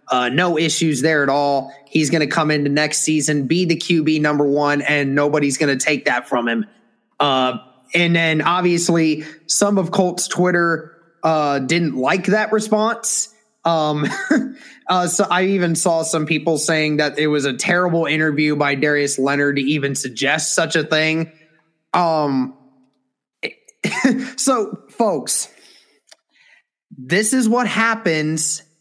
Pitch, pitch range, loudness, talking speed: 155 Hz, 145-180 Hz, -18 LUFS, 140 wpm